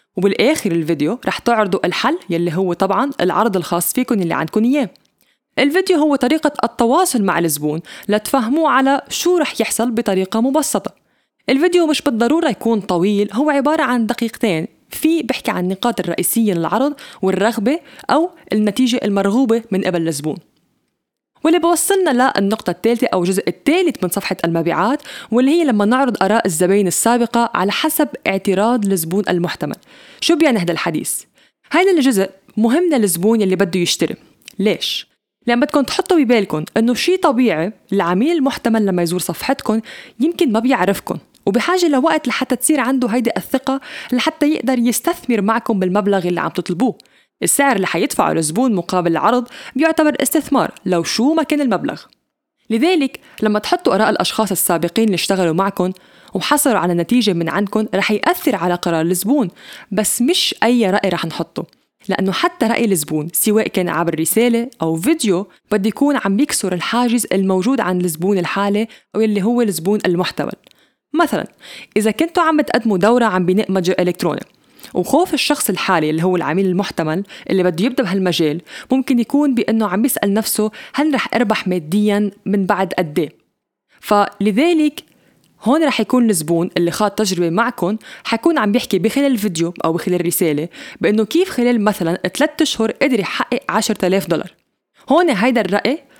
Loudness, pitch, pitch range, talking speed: -16 LUFS, 220 Hz, 190-270 Hz, 150 wpm